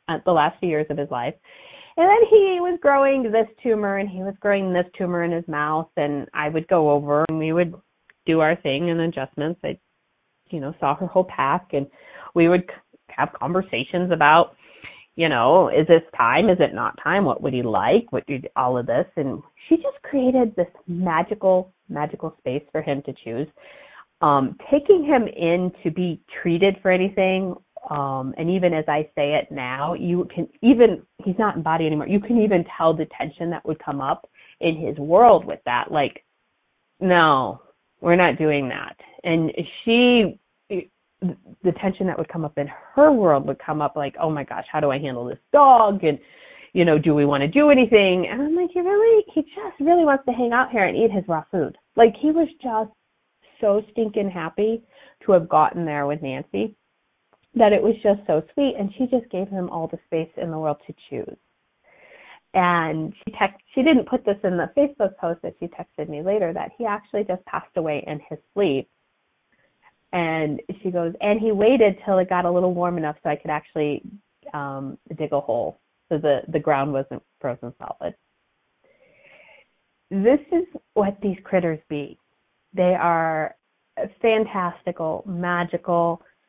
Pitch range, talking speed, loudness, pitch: 155-215 Hz, 190 wpm, -21 LUFS, 180 Hz